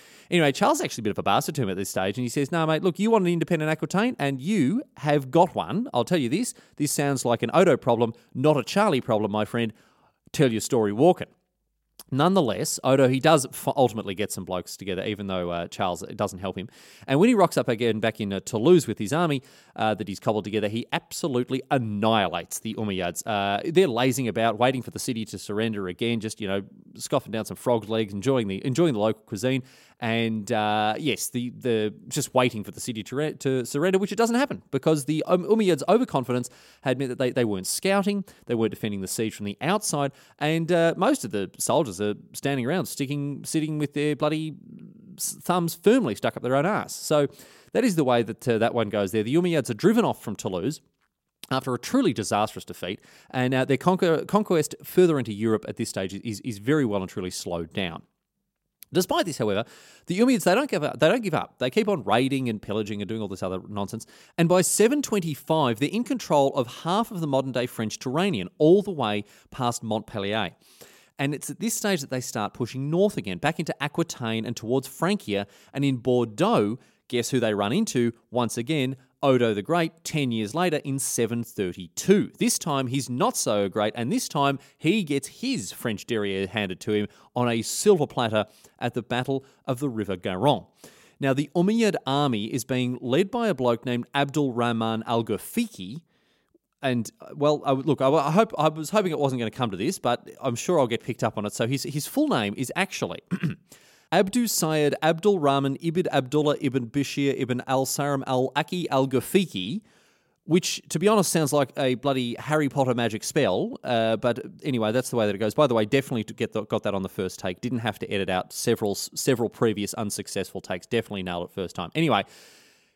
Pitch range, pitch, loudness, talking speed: 110-160 Hz, 130 Hz, -25 LUFS, 210 wpm